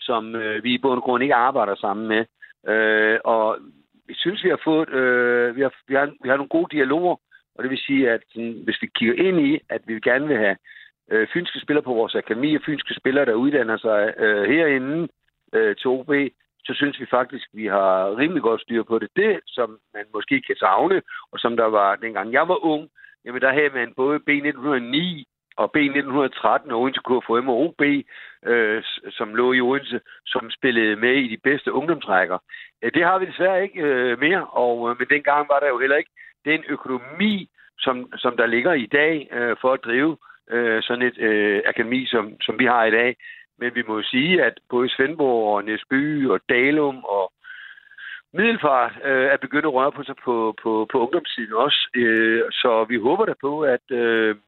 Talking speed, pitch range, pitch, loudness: 205 wpm, 115-150 Hz, 130 Hz, -21 LUFS